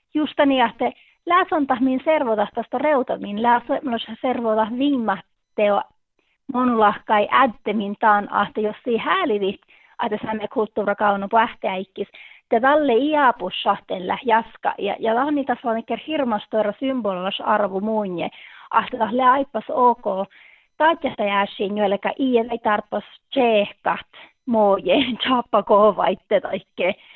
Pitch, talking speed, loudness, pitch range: 225 Hz, 110 wpm, -21 LUFS, 210-260 Hz